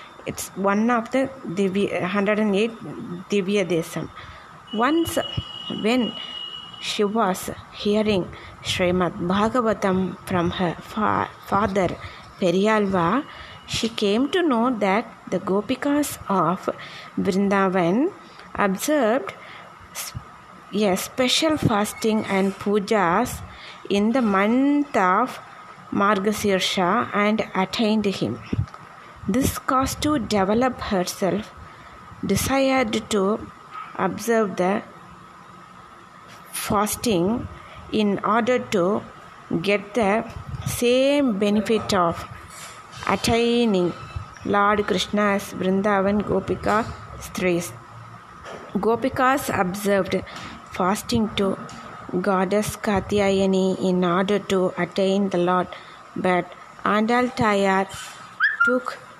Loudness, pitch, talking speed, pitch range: -22 LUFS, 205 Hz, 85 wpm, 190-230 Hz